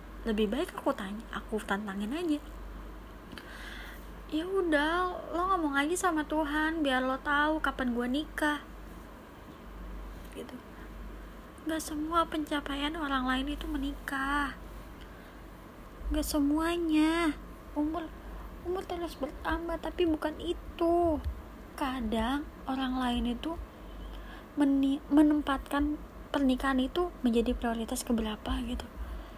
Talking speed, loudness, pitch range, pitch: 100 wpm, -31 LUFS, 260-320 Hz, 290 Hz